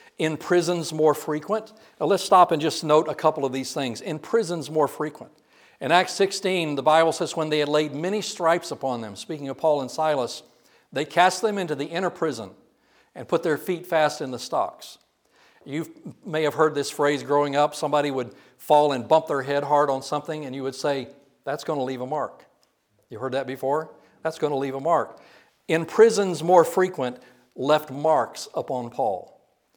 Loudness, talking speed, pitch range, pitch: -24 LUFS, 200 wpm, 140-165 Hz, 155 Hz